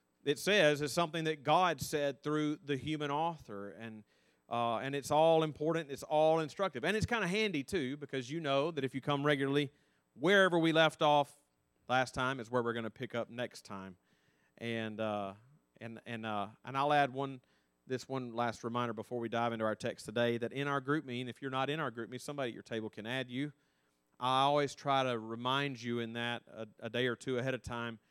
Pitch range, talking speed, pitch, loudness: 115-145 Hz, 220 wpm, 130 Hz, -34 LUFS